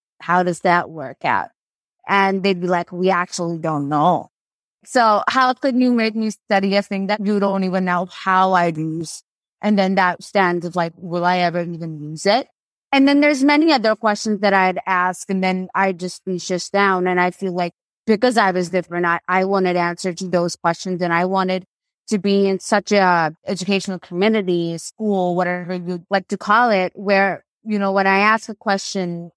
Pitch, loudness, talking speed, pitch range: 185 Hz, -18 LUFS, 200 wpm, 175-200 Hz